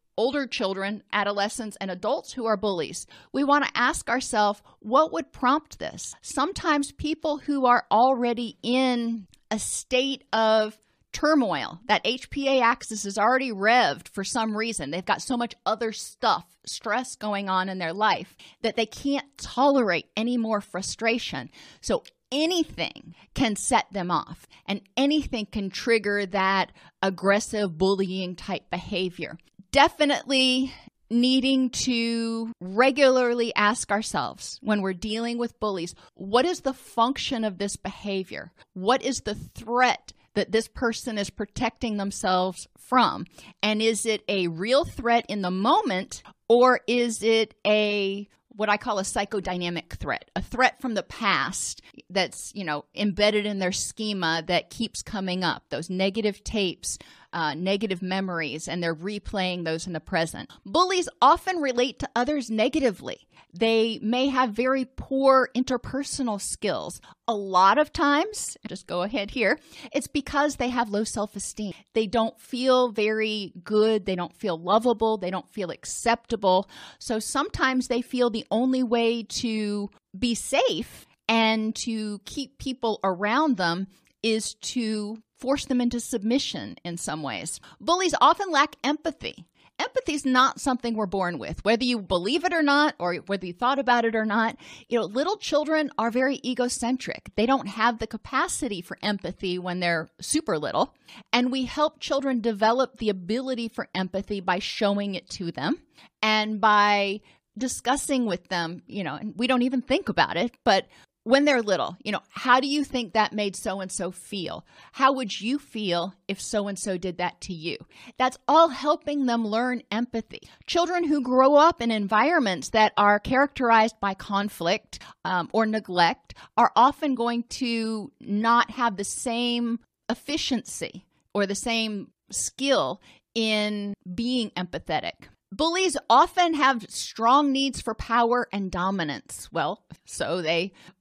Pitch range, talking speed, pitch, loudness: 200-255 Hz, 155 wpm, 225 Hz, -25 LUFS